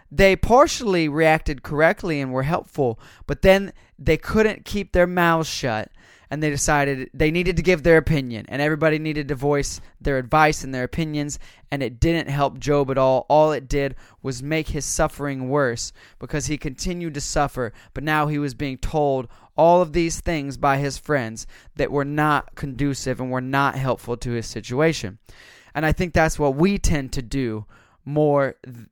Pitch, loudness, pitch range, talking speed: 145 Hz, -21 LUFS, 130-160 Hz, 185 wpm